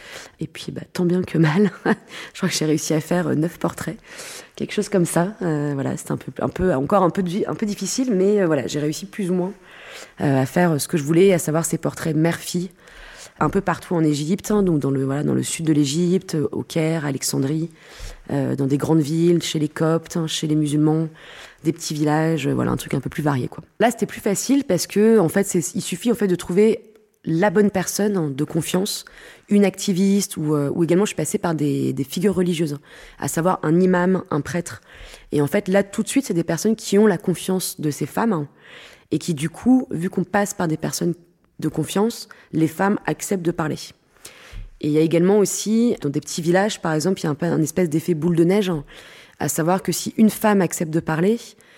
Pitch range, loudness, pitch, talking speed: 155-195 Hz, -21 LUFS, 175 Hz, 230 wpm